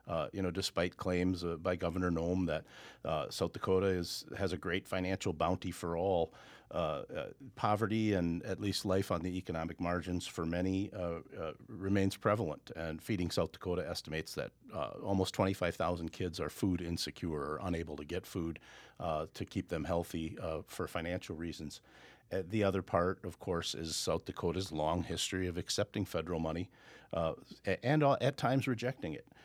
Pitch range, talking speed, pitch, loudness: 85-95 Hz, 180 wpm, 90 Hz, -37 LUFS